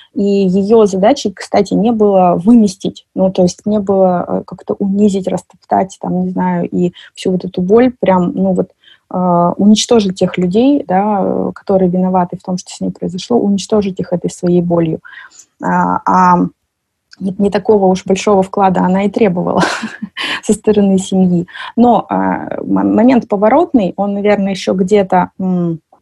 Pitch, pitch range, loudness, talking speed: 190 Hz, 180-210 Hz, -13 LUFS, 150 wpm